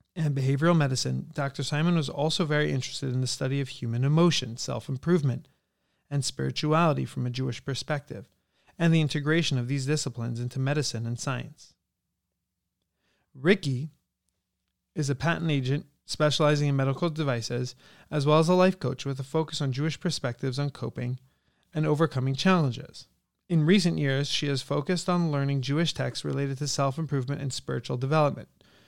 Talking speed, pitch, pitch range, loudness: 160 wpm, 140 Hz, 130-155 Hz, -27 LUFS